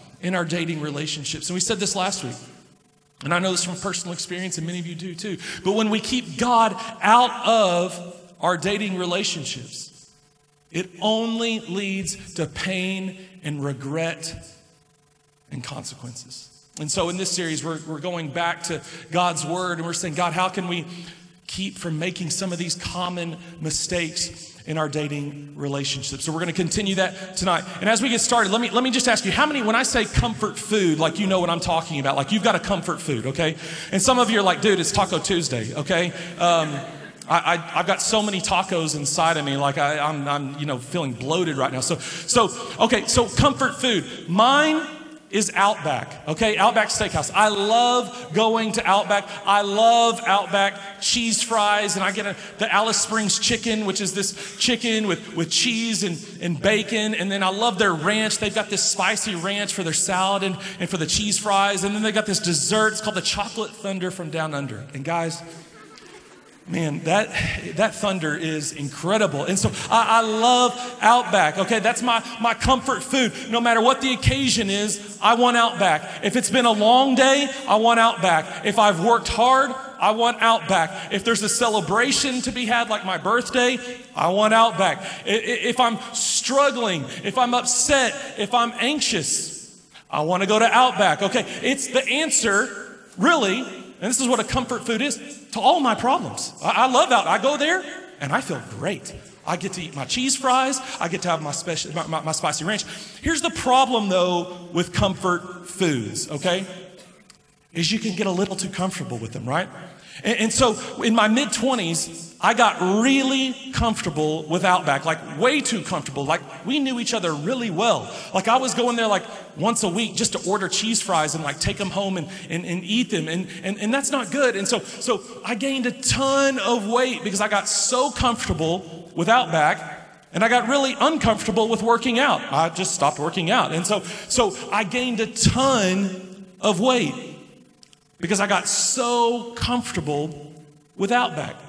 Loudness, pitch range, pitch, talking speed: -21 LUFS, 170-230 Hz, 200 Hz, 190 wpm